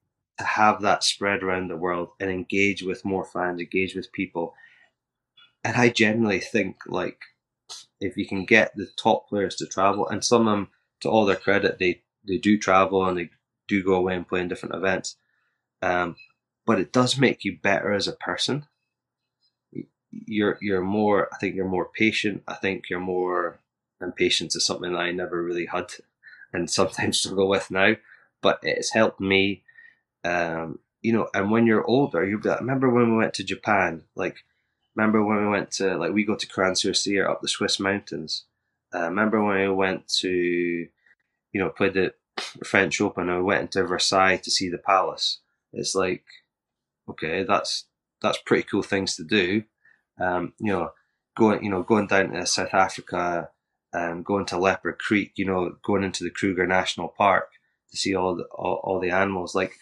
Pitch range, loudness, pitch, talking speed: 90-105 Hz, -24 LUFS, 95 Hz, 185 wpm